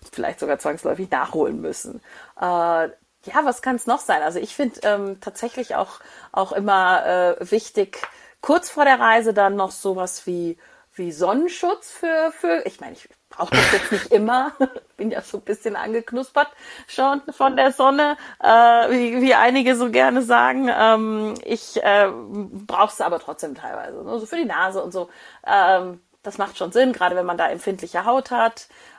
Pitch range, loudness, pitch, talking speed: 195-265 Hz, -20 LUFS, 230 Hz, 180 wpm